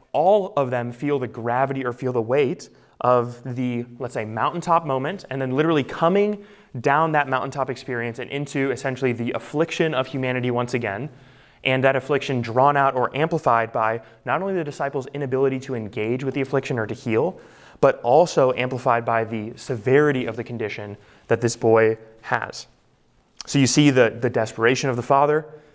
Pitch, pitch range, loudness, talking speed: 130 Hz, 120-140 Hz, -22 LUFS, 175 wpm